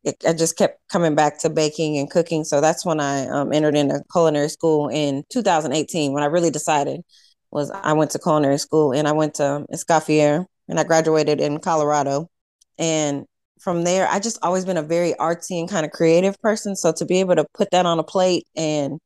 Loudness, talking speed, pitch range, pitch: -20 LUFS, 210 wpm, 150-170 Hz, 160 Hz